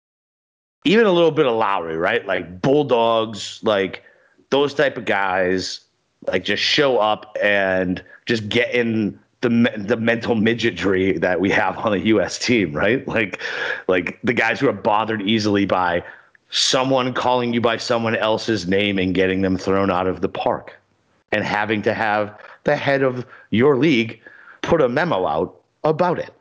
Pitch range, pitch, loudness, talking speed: 95-120 Hz, 110 Hz, -19 LUFS, 165 wpm